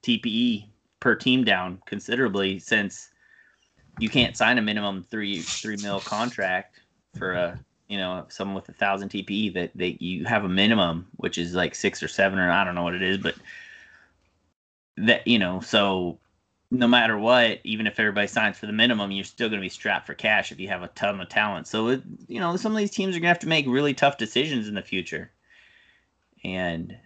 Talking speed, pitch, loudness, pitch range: 215 wpm, 100 Hz, -24 LUFS, 95-125 Hz